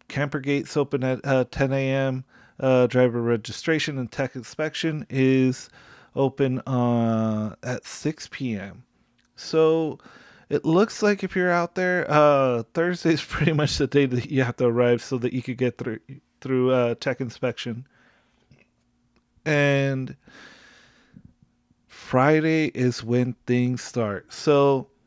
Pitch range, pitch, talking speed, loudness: 125-150 Hz, 130 Hz, 135 wpm, -23 LUFS